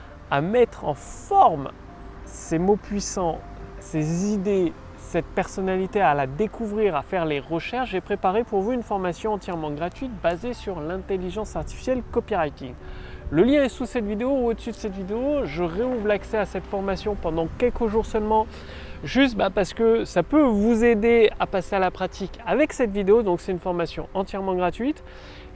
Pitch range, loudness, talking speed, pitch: 185-235 Hz, -24 LUFS, 170 wpm, 205 Hz